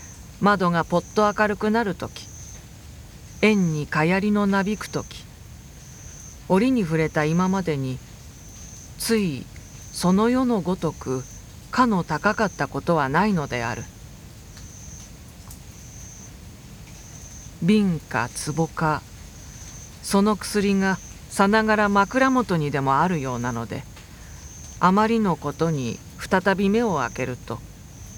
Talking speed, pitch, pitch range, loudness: 200 characters per minute, 165 Hz, 130-205 Hz, -22 LUFS